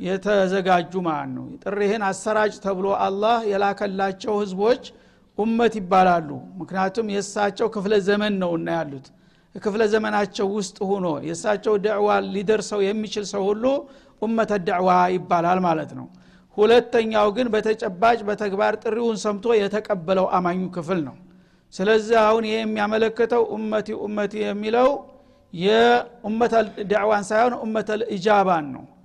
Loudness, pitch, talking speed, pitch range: -22 LUFS, 210 Hz, 110 wpm, 190-220 Hz